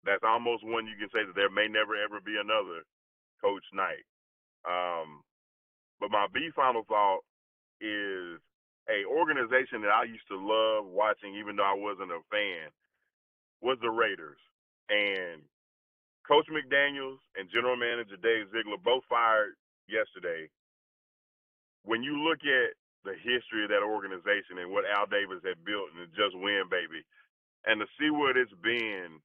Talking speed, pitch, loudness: 155 wpm, 120 Hz, -30 LUFS